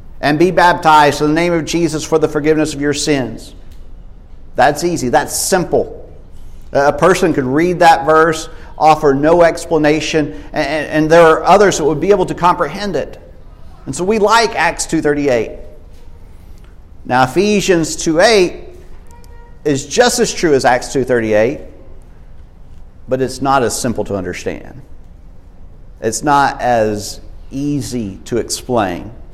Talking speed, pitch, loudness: 140 wpm, 145 Hz, -13 LUFS